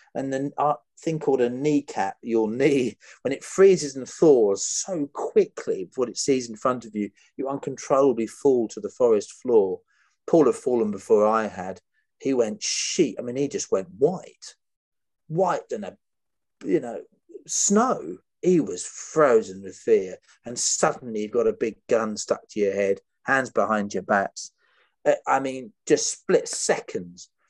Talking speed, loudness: 170 wpm, -24 LUFS